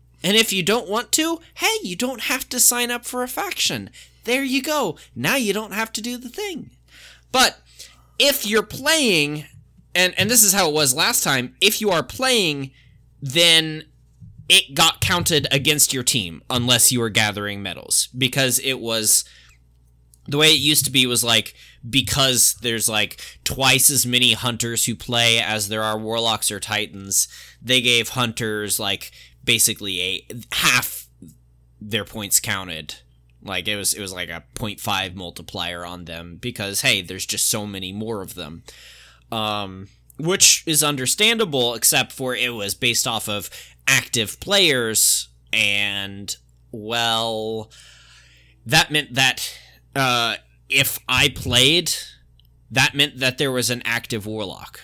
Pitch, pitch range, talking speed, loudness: 115 Hz, 100-145 Hz, 155 wpm, -18 LUFS